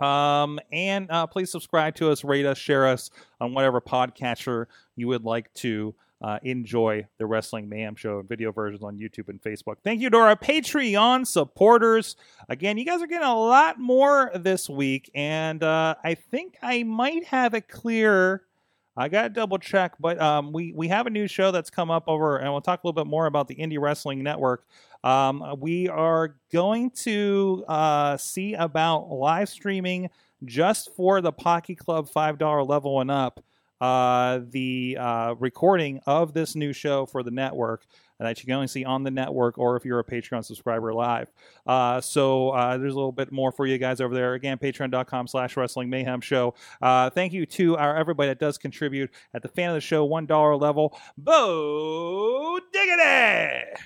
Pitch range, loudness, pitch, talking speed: 130-180 Hz, -24 LUFS, 145 Hz, 185 wpm